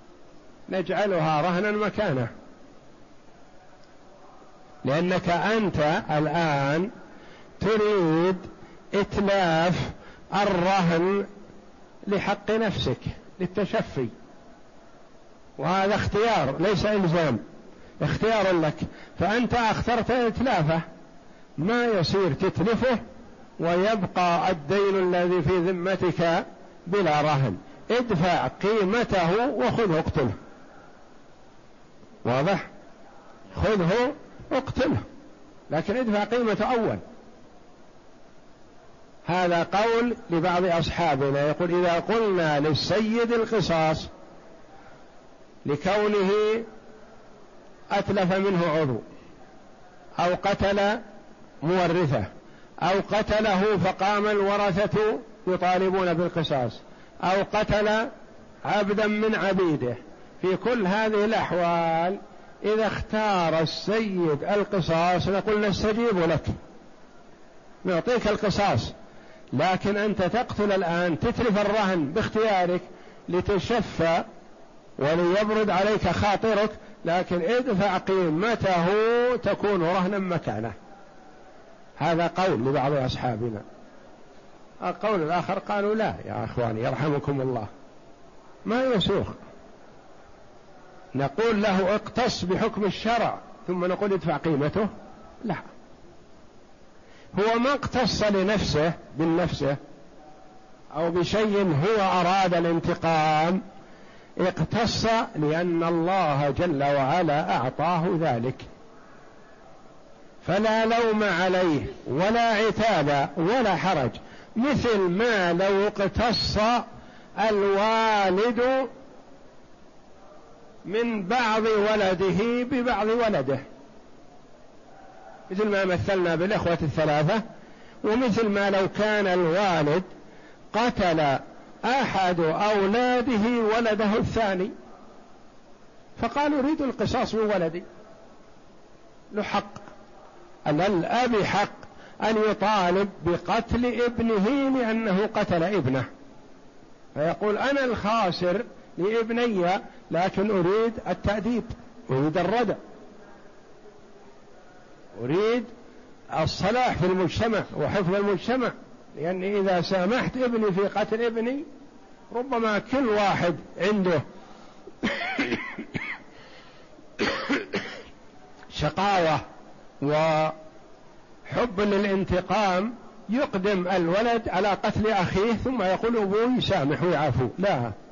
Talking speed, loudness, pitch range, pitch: 75 wpm, -25 LUFS, 170-215 Hz, 195 Hz